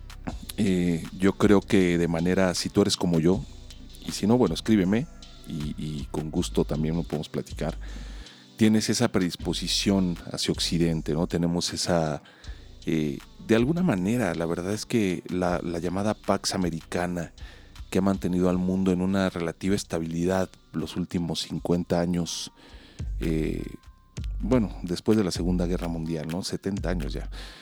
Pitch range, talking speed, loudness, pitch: 80-95 Hz, 150 wpm, -26 LUFS, 90 Hz